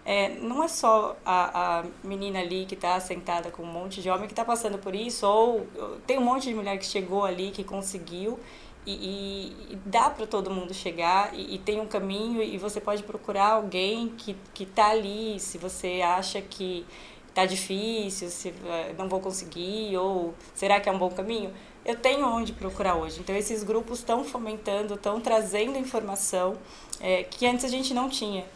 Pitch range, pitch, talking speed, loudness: 185-220 Hz, 200 Hz, 195 wpm, -28 LUFS